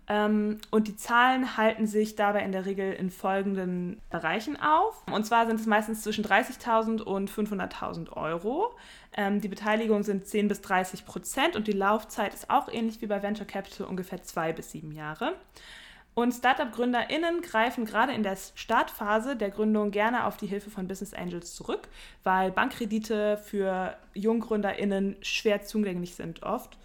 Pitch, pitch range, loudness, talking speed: 210 Hz, 195-225 Hz, -29 LUFS, 160 wpm